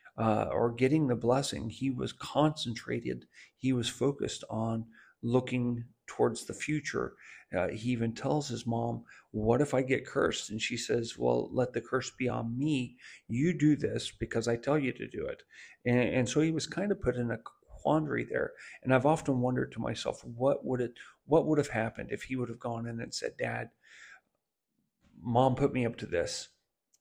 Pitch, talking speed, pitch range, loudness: 125 Hz, 195 wpm, 115-140 Hz, -32 LUFS